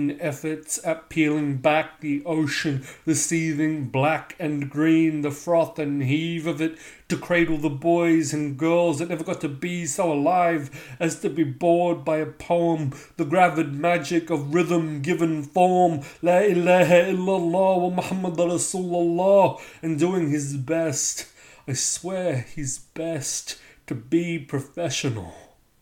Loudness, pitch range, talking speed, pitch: -23 LUFS, 150-175 Hz, 140 wpm, 160 Hz